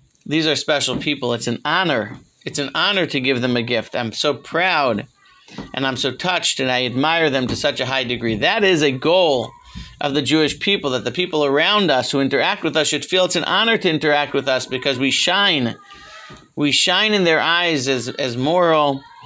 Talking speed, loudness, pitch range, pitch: 210 wpm, -18 LUFS, 130-160 Hz, 145 Hz